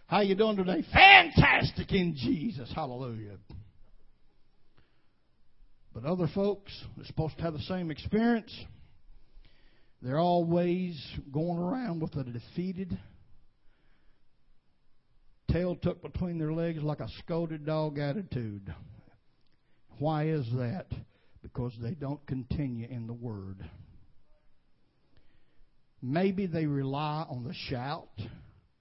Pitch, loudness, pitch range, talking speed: 145 Hz, -29 LUFS, 115-170 Hz, 105 wpm